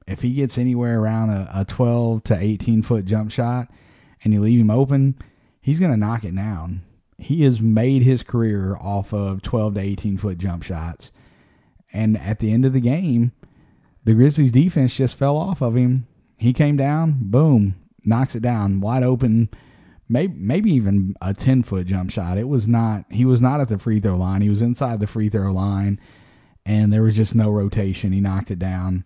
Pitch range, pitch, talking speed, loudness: 100-125 Hz, 110 Hz, 200 wpm, -19 LUFS